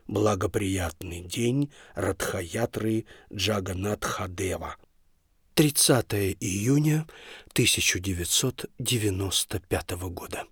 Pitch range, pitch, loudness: 95-115 Hz, 100 Hz, -26 LUFS